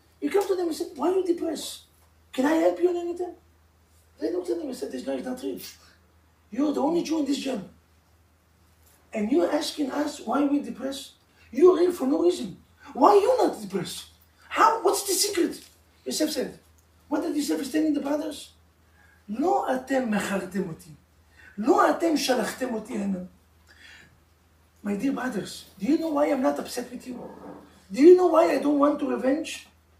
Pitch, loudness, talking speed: 275 Hz, -25 LUFS, 180 wpm